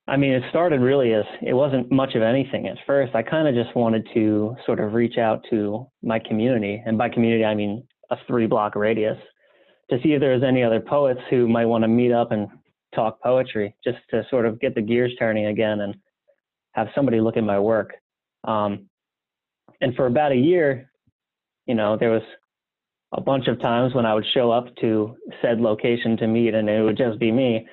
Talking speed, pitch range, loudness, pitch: 210 wpm, 110-125 Hz, -21 LUFS, 115 Hz